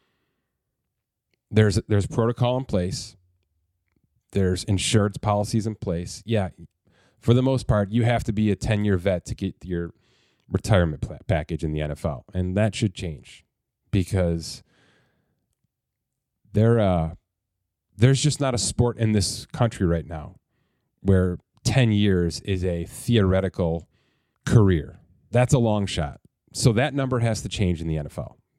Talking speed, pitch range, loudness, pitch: 145 wpm, 90-115 Hz, -24 LUFS, 100 Hz